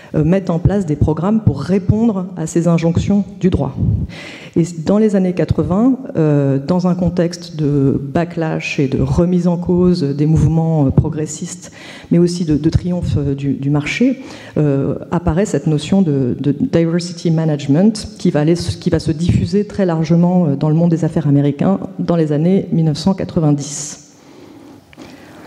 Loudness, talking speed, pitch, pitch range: -16 LUFS, 155 wpm, 170 Hz, 150-185 Hz